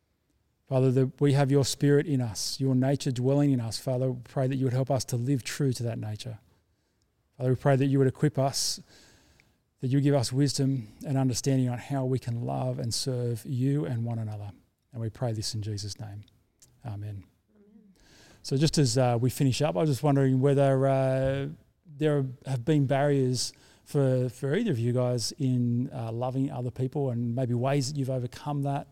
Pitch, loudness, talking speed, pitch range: 130 Hz, -28 LUFS, 200 wpm, 120-140 Hz